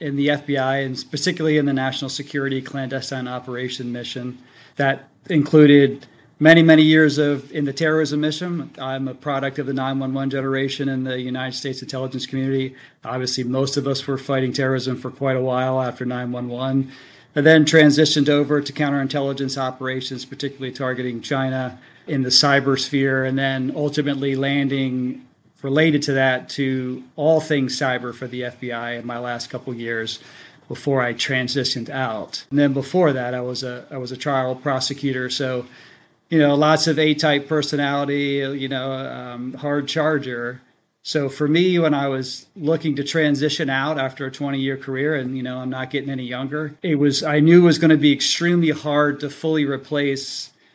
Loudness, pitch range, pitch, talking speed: -20 LUFS, 130-145 Hz, 135 Hz, 175 wpm